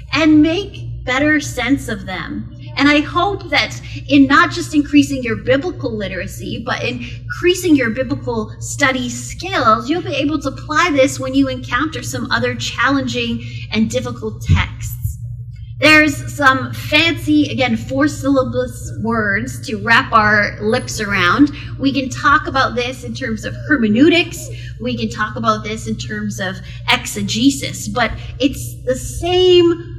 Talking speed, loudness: 145 wpm, -16 LUFS